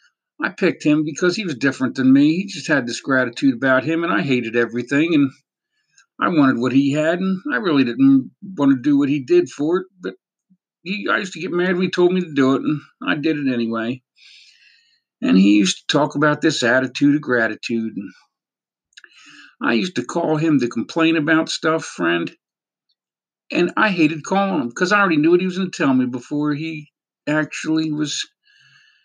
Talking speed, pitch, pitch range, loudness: 200 wpm, 155 Hz, 135-185 Hz, -19 LUFS